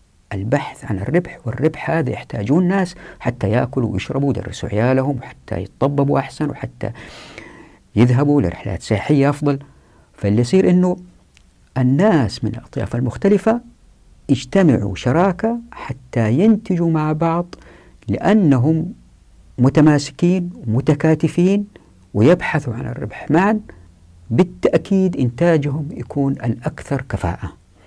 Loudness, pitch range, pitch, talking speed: -18 LUFS, 115-170 Hz, 140 Hz, 95 wpm